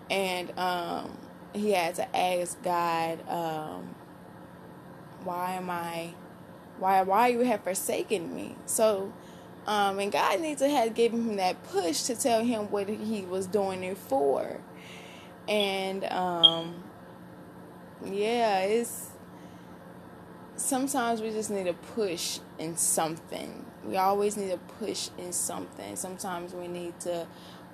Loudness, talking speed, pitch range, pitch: -29 LUFS, 130 wpm, 170-210 Hz, 185 Hz